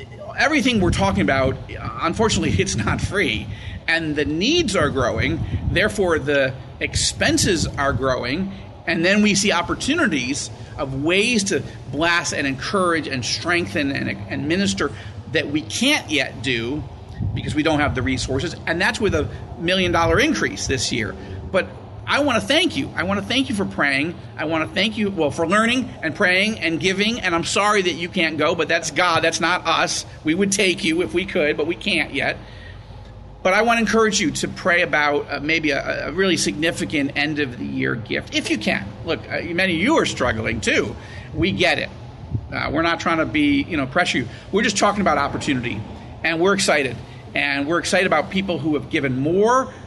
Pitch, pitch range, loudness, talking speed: 160 Hz, 125-185 Hz, -20 LUFS, 195 wpm